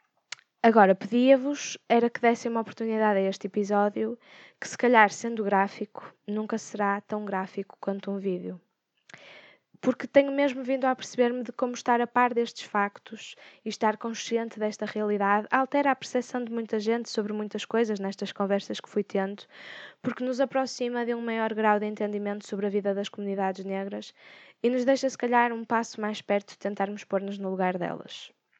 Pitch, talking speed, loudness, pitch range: 215 Hz, 175 wpm, -27 LUFS, 200-240 Hz